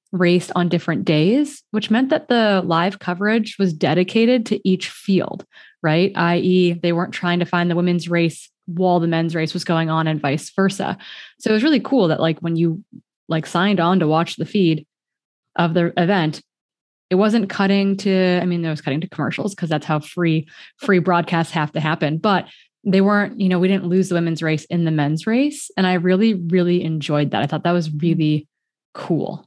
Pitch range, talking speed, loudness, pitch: 165-195 Hz, 205 wpm, -19 LUFS, 175 Hz